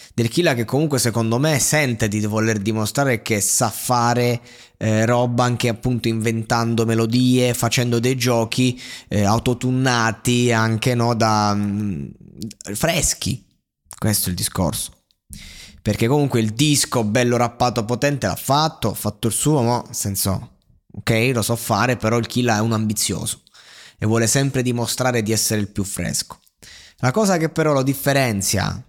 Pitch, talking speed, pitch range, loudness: 120 Hz, 150 wpm, 110-125 Hz, -19 LUFS